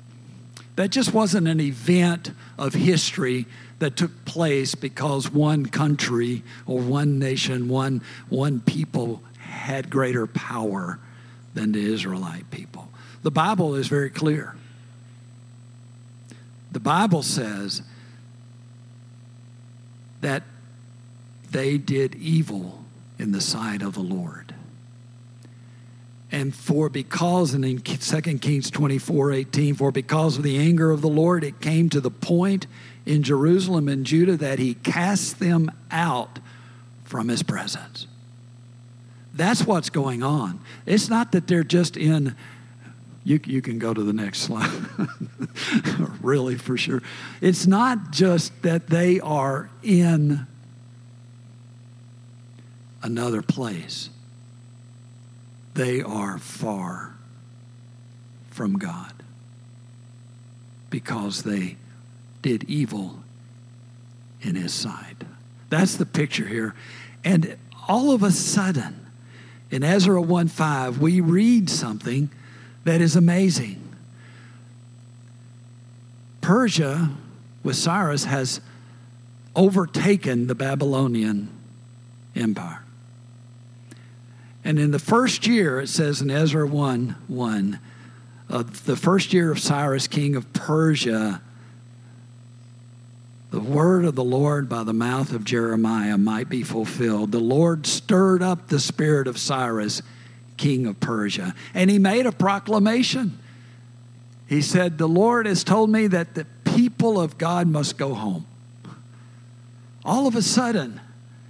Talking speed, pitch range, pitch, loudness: 115 wpm, 120-155 Hz, 125 Hz, -22 LUFS